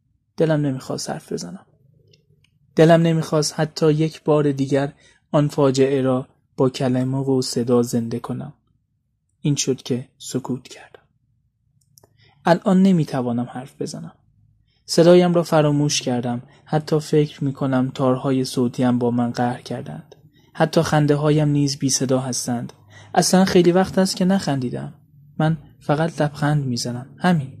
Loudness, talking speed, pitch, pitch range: -20 LUFS, 130 wpm, 140 Hz, 125-155 Hz